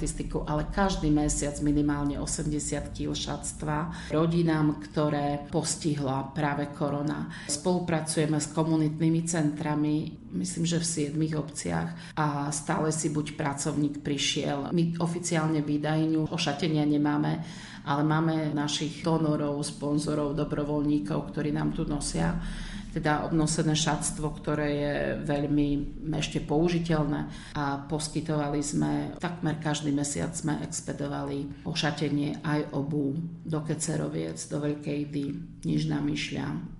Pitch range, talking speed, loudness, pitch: 145-160 Hz, 115 wpm, -29 LUFS, 150 Hz